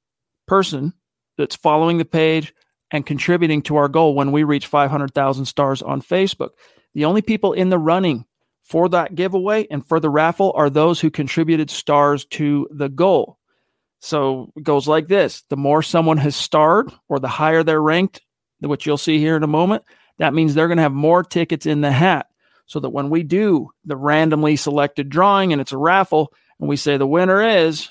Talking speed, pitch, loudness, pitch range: 195 wpm, 155 Hz, -17 LUFS, 145-170 Hz